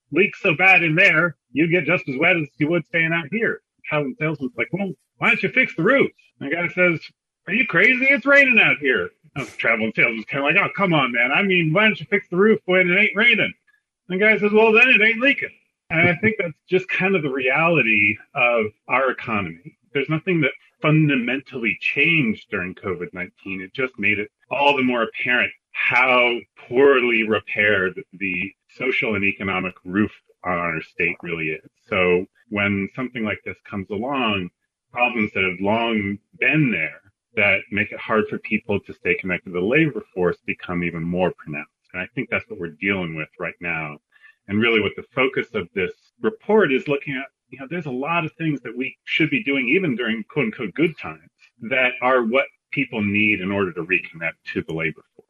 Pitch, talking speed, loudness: 140 Hz, 205 wpm, -19 LUFS